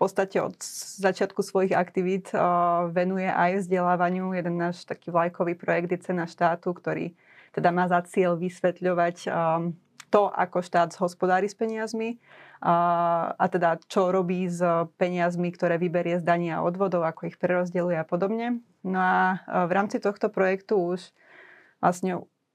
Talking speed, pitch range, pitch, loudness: 155 wpm, 175-190 Hz, 180 Hz, -26 LUFS